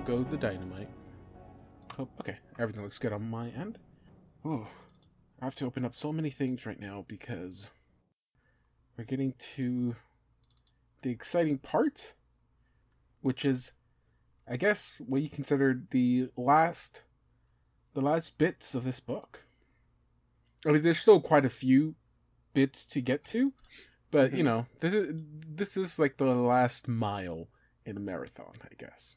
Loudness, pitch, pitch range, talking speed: -31 LUFS, 130 Hz, 115-150 Hz, 145 wpm